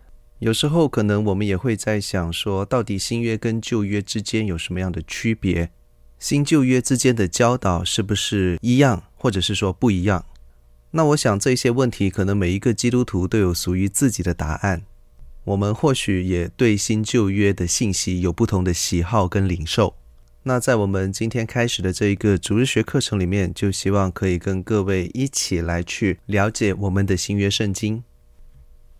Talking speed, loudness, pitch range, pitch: 275 characters per minute, -21 LUFS, 90-115 Hz, 100 Hz